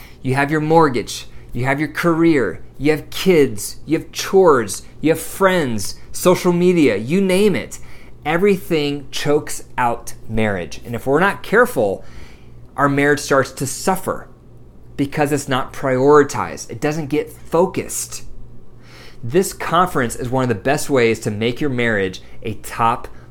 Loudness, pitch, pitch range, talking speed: -18 LUFS, 145 Hz, 120-165 Hz, 150 wpm